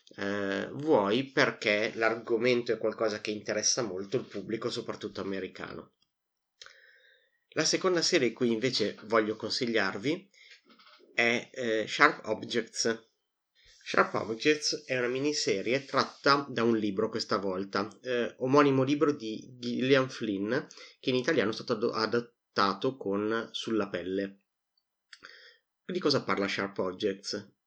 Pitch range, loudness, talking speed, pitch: 105-130 Hz, -30 LUFS, 120 wpm, 115 Hz